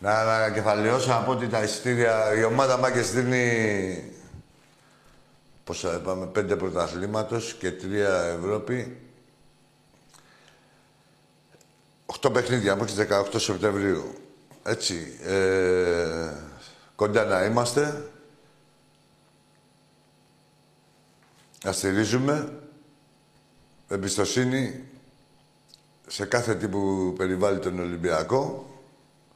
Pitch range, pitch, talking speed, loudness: 100-130 Hz, 110 Hz, 80 wpm, -25 LUFS